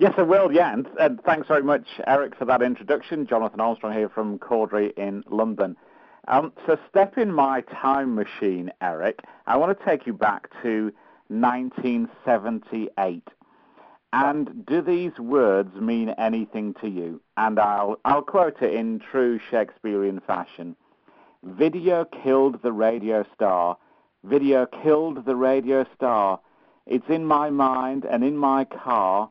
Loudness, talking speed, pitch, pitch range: -23 LUFS, 145 wpm, 125 Hz, 110-145 Hz